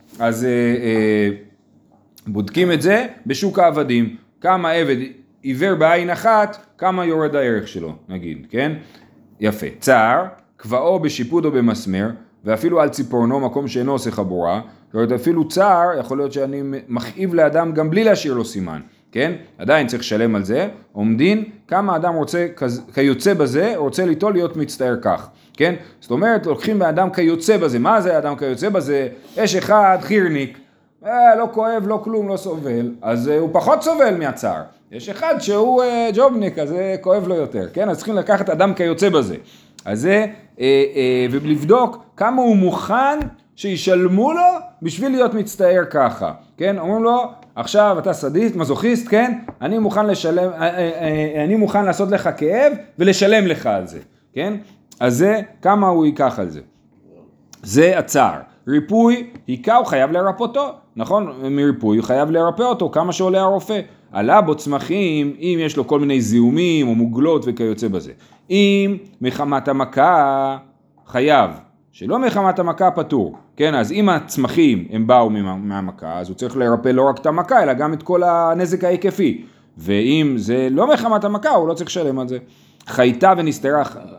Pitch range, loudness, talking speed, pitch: 135-200 Hz, -17 LUFS, 160 wpm, 170 Hz